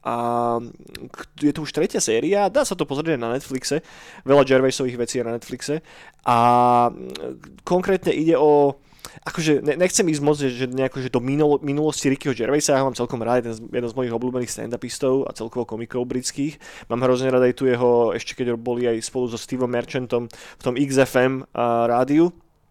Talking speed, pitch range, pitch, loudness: 175 wpm, 120-145 Hz, 130 Hz, -21 LUFS